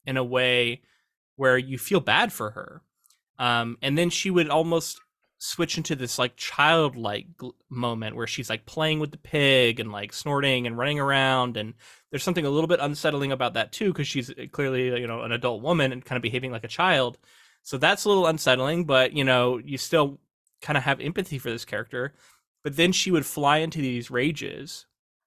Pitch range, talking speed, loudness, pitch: 125-155 Hz, 200 wpm, -24 LUFS, 135 Hz